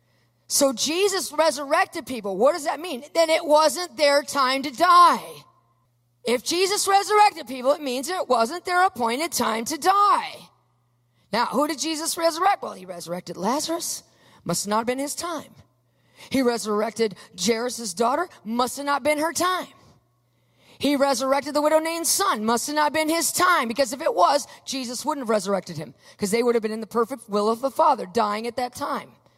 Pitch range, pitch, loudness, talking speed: 225-325 Hz, 275 Hz, -22 LUFS, 185 wpm